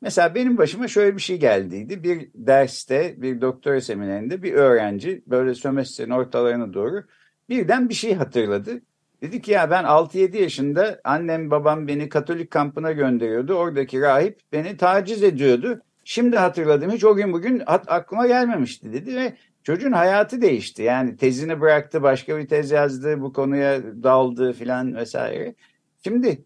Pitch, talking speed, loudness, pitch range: 155 Hz, 145 wpm, -21 LUFS, 130-200 Hz